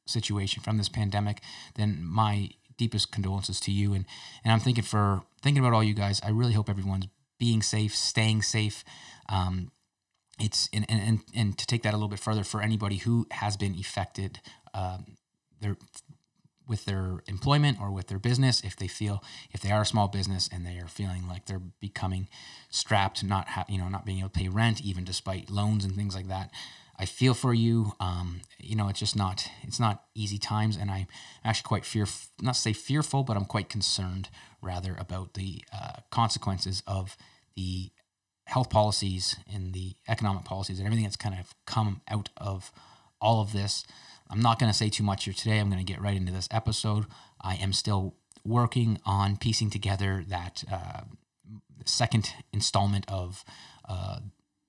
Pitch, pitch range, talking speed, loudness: 105 Hz, 95-110 Hz, 185 wpm, -29 LUFS